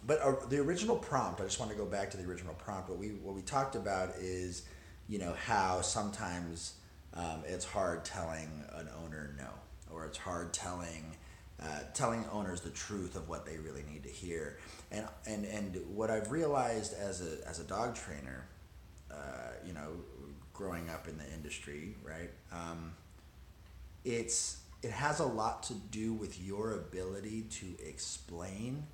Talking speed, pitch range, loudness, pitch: 170 wpm, 80-105 Hz, -39 LUFS, 90 Hz